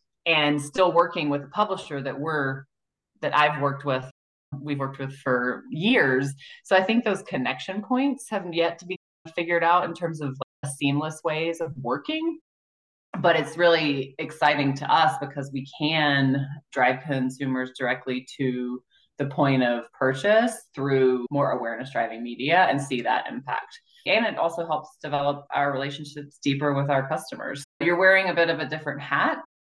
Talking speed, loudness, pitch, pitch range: 165 wpm, -25 LUFS, 145 Hz, 135-170 Hz